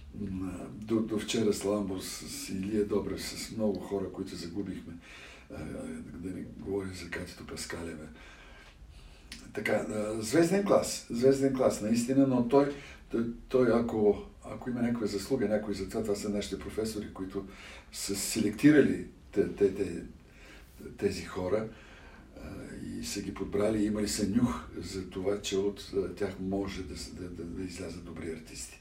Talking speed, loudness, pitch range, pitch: 135 wpm, -32 LUFS, 95-110 Hz, 100 Hz